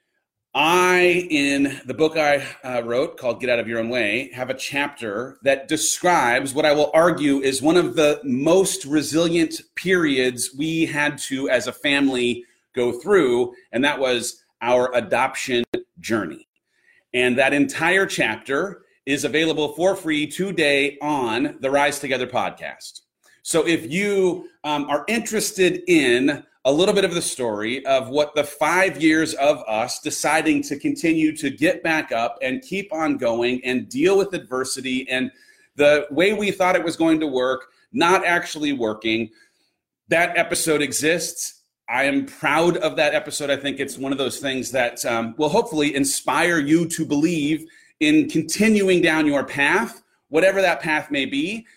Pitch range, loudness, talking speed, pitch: 135-180 Hz, -20 LUFS, 160 wpm, 155 Hz